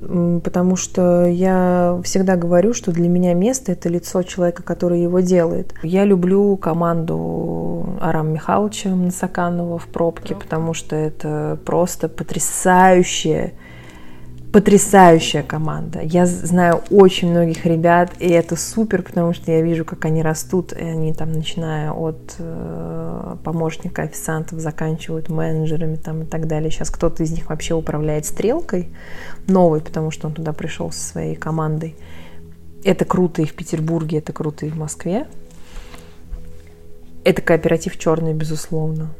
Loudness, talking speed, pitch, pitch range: -18 LUFS, 135 wpm, 165 Hz, 155-175 Hz